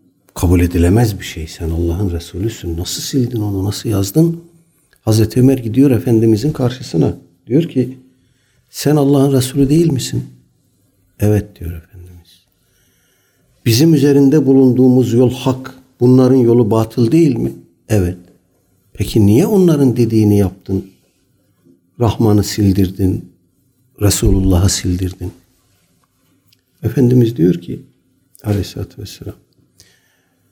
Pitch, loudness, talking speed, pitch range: 110 Hz, -14 LUFS, 100 wpm, 95-130 Hz